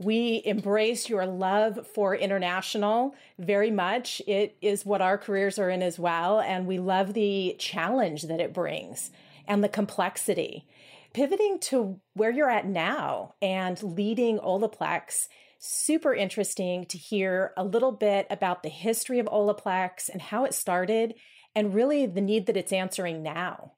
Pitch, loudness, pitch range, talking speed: 200 Hz, -27 LUFS, 185-220 Hz, 155 wpm